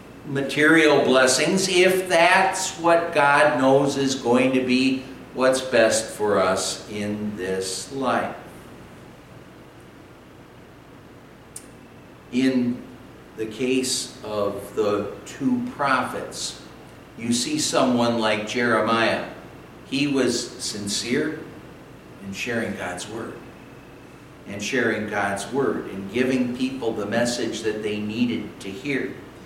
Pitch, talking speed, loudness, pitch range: 125 Hz, 105 wpm, -22 LUFS, 105-140 Hz